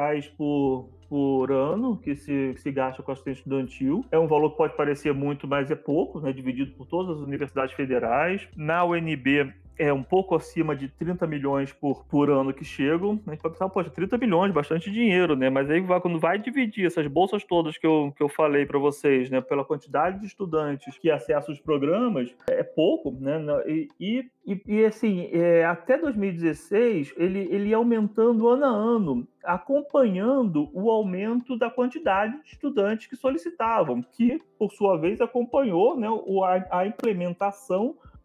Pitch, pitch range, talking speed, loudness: 170 Hz, 145-220 Hz, 180 wpm, -25 LUFS